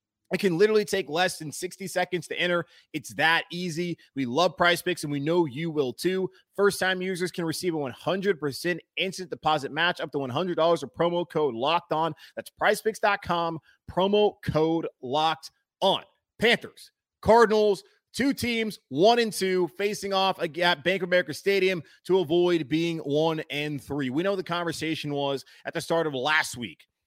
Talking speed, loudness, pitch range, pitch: 175 wpm, -26 LUFS, 155-185 Hz, 175 Hz